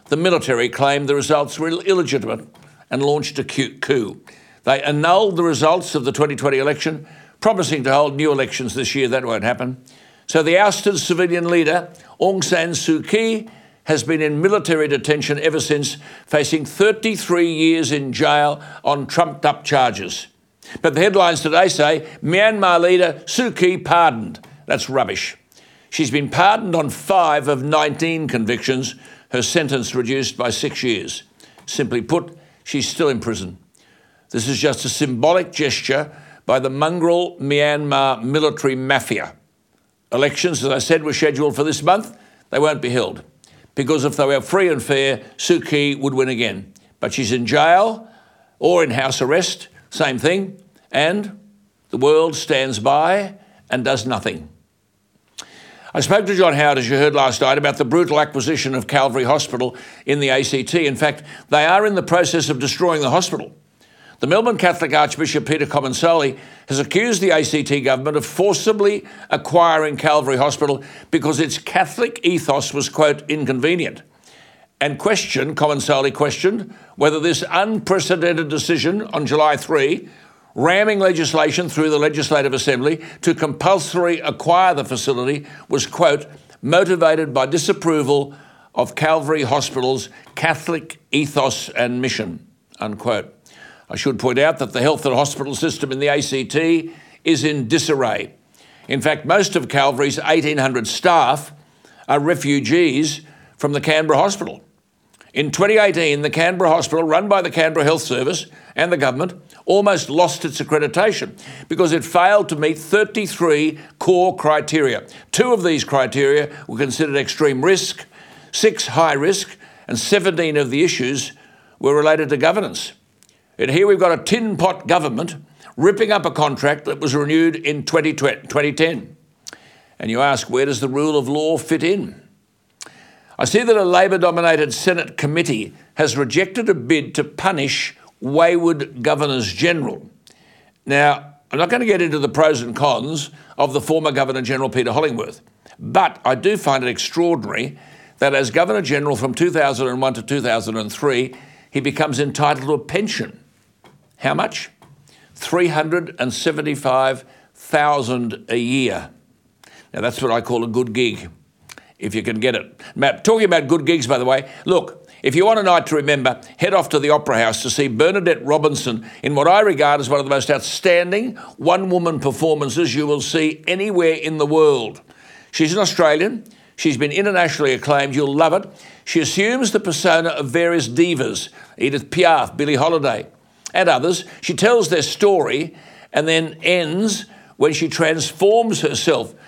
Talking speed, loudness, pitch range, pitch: 150 wpm, -17 LUFS, 140-175 Hz, 155 Hz